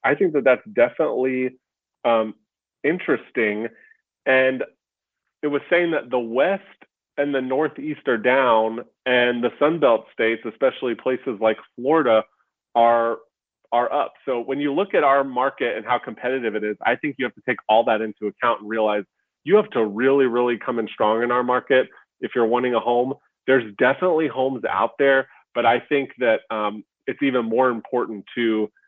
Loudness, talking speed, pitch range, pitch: -21 LUFS, 175 wpm, 115-135 Hz, 125 Hz